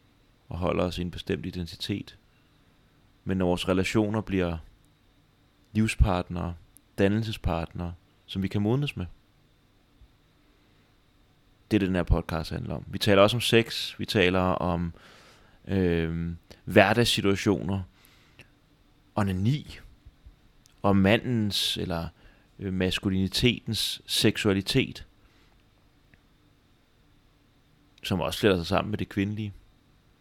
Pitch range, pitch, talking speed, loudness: 90-110 Hz, 100 Hz, 105 wpm, -27 LUFS